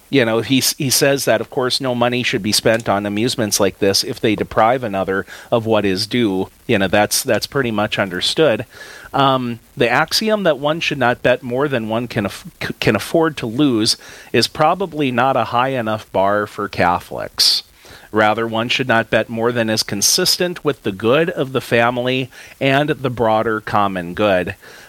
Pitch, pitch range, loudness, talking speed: 120 Hz, 110-135 Hz, -17 LUFS, 190 wpm